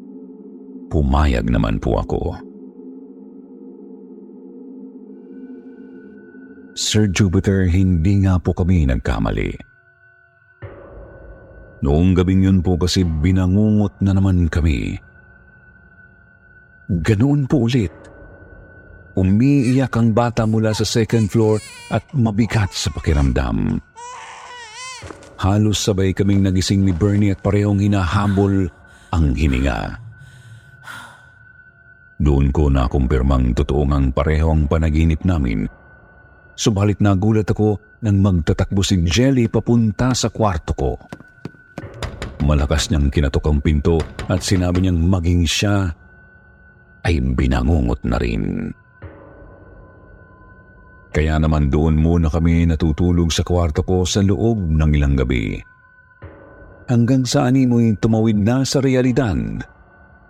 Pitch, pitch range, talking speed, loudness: 95 Hz, 85-115 Hz, 100 wpm, -18 LUFS